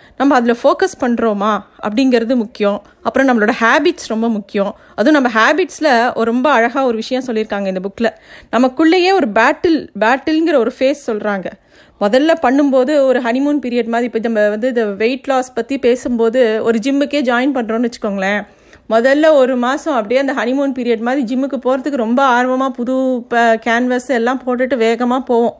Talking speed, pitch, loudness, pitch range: 150 wpm, 245 Hz, -14 LUFS, 230-270 Hz